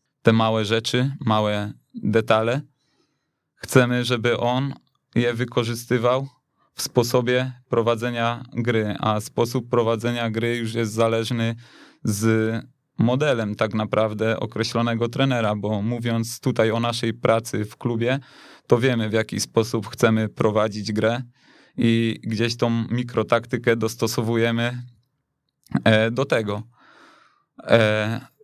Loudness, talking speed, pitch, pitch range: -22 LUFS, 105 wpm, 115 Hz, 110-125 Hz